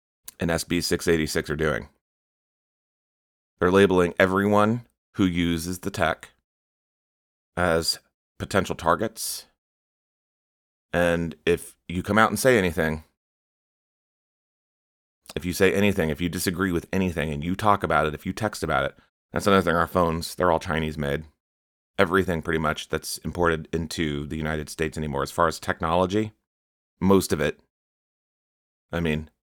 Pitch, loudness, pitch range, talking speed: 85 Hz, -24 LUFS, 80-95 Hz, 145 wpm